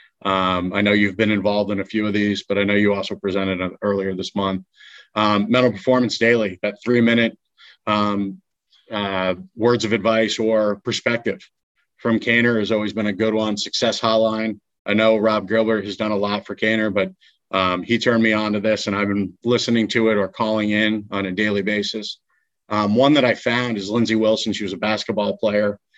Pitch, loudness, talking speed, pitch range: 105 Hz, -20 LUFS, 205 wpm, 100-110 Hz